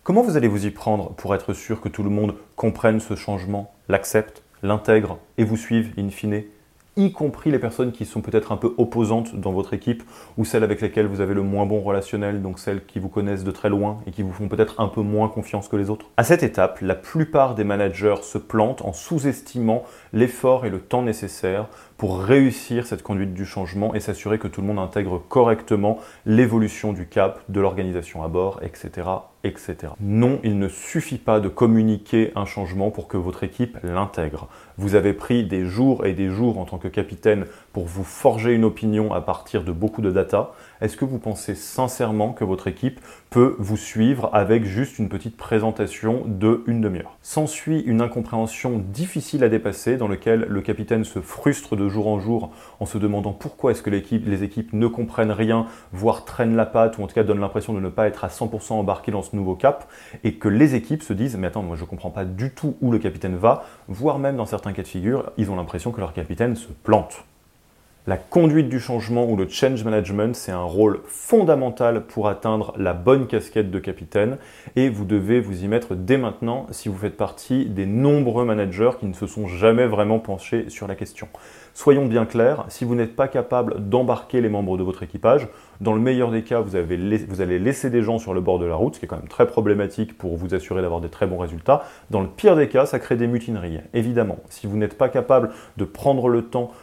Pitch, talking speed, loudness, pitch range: 105 Hz, 220 wpm, -22 LUFS, 100-120 Hz